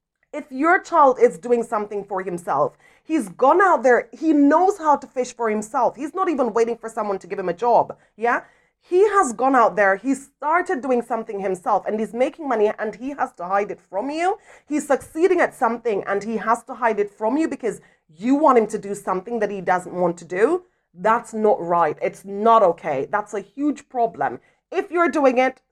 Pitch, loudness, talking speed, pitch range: 240 Hz, -21 LUFS, 215 wpm, 205-290 Hz